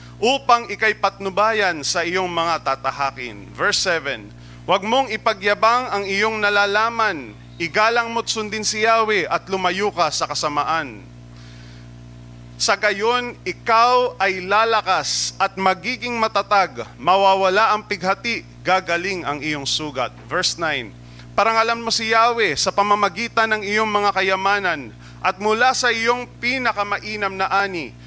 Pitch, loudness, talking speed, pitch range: 200 Hz, -19 LUFS, 125 wpm, 155-220 Hz